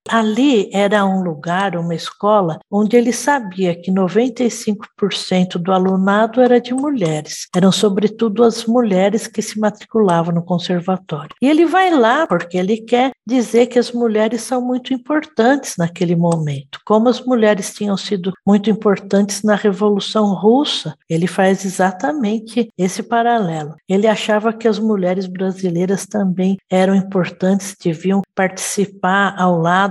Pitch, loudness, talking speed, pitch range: 205 Hz, -16 LUFS, 140 wpm, 185-230 Hz